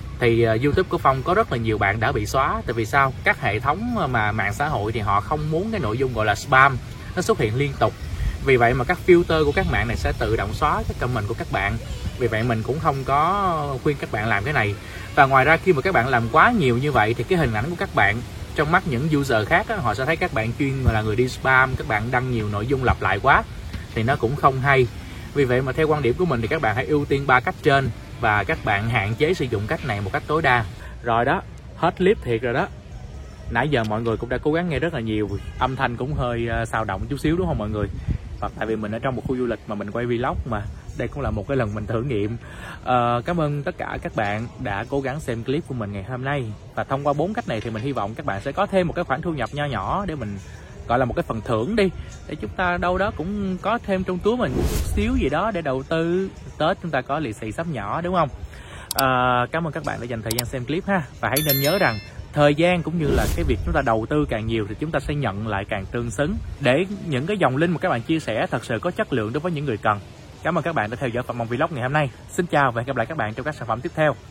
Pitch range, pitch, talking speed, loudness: 110-155 Hz, 130 Hz, 290 wpm, -22 LUFS